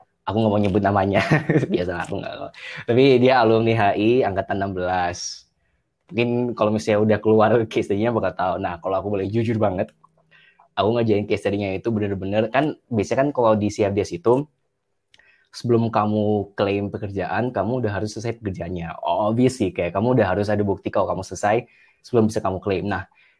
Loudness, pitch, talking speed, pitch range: -21 LUFS, 105 Hz, 170 wpm, 100-115 Hz